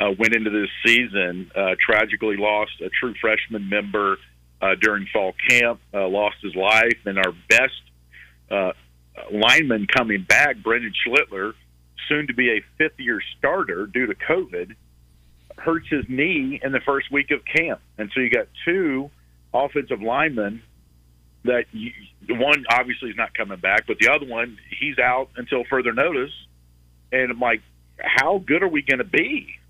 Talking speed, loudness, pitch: 165 wpm, -20 LUFS, 105 Hz